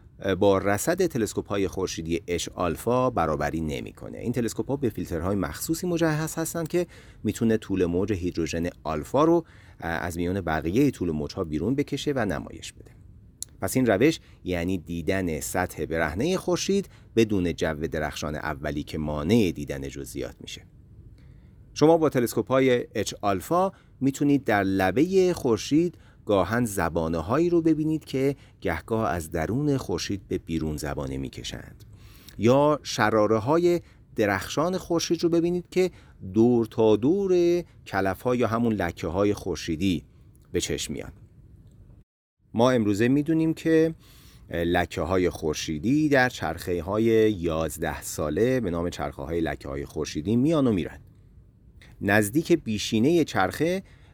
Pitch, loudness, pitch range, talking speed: 110 Hz, -25 LUFS, 85-140 Hz, 135 wpm